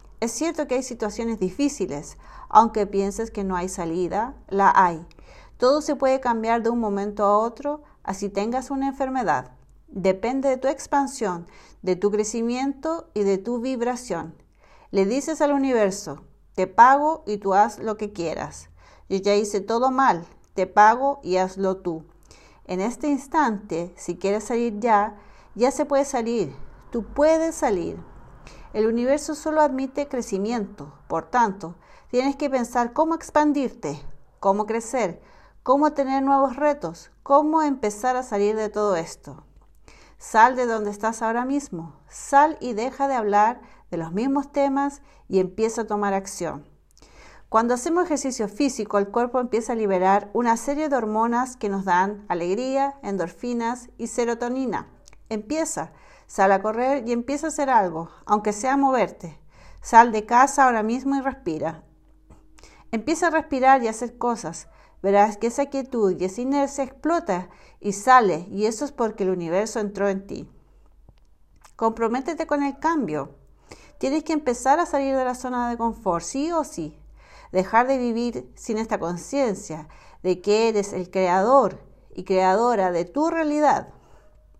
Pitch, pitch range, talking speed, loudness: 230 Hz, 195-275 Hz, 155 wpm, -23 LUFS